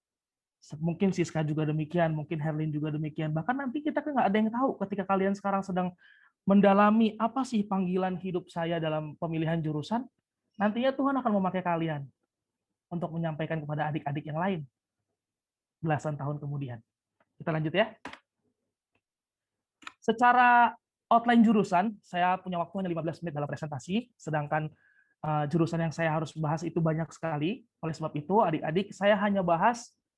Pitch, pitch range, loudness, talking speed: 170 Hz, 155-205 Hz, -29 LUFS, 145 wpm